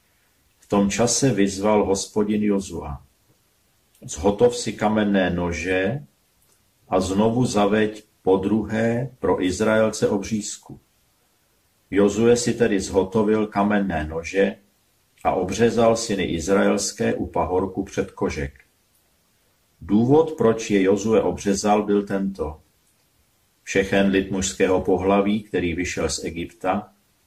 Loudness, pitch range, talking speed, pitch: -21 LUFS, 95-110 Hz, 105 wpm, 100 Hz